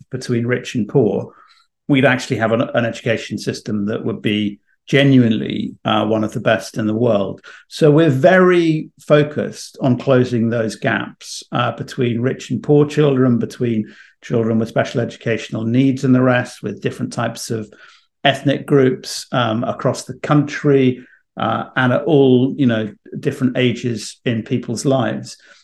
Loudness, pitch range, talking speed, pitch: -17 LUFS, 115-140 Hz, 155 wpm, 125 Hz